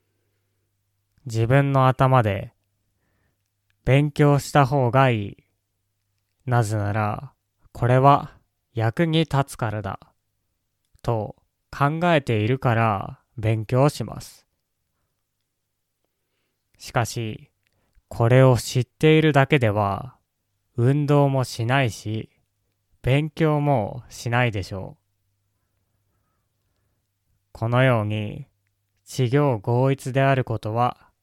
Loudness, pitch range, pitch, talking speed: -21 LUFS, 100-130 Hz, 110 Hz, 165 characters per minute